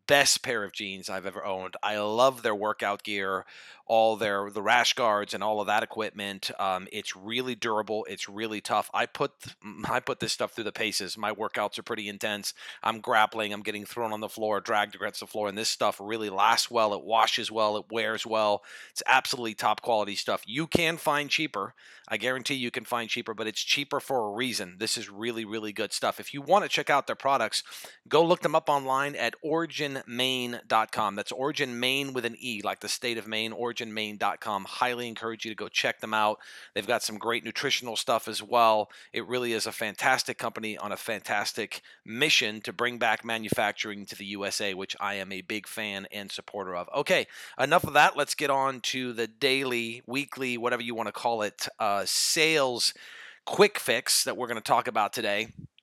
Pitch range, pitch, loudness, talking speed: 105-125 Hz, 110 Hz, -28 LUFS, 210 wpm